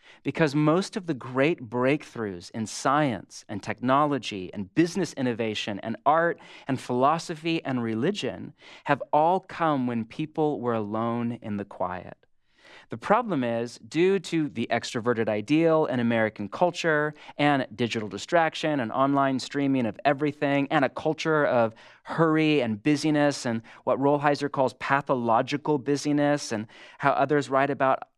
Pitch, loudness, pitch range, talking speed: 135 Hz, -26 LUFS, 115-150 Hz, 140 wpm